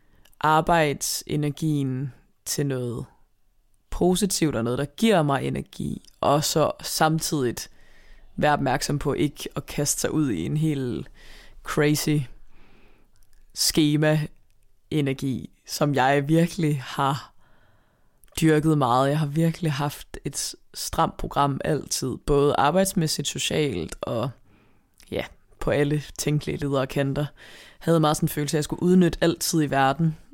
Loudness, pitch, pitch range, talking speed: -24 LUFS, 145 Hz, 135-155 Hz, 125 wpm